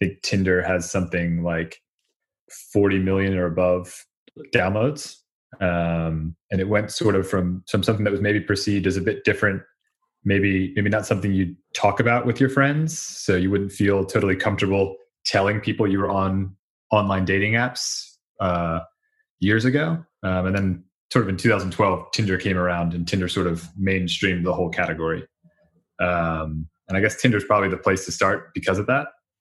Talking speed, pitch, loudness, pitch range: 180 wpm, 95 Hz, -22 LUFS, 90-105 Hz